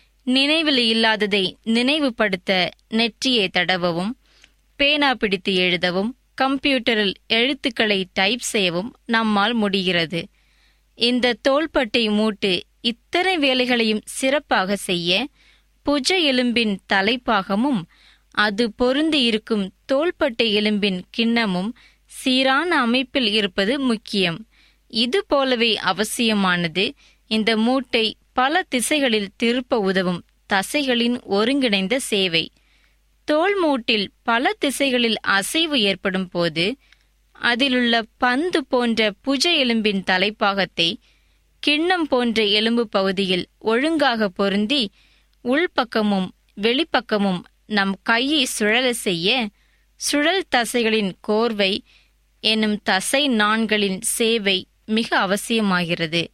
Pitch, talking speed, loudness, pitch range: 225 Hz, 85 wpm, -20 LUFS, 200-260 Hz